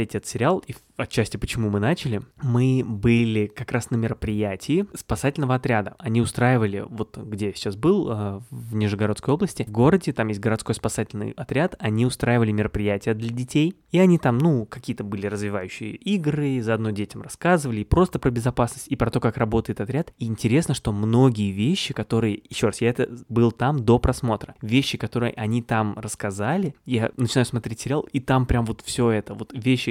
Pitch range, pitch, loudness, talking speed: 110-130 Hz, 120 Hz, -23 LUFS, 180 wpm